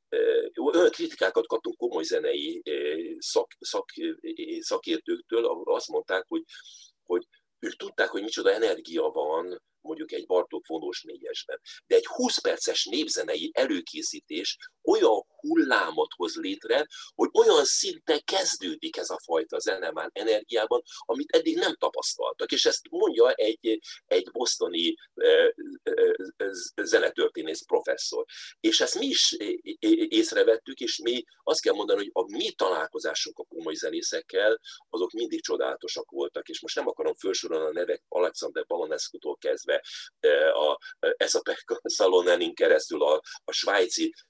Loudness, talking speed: -27 LUFS, 130 wpm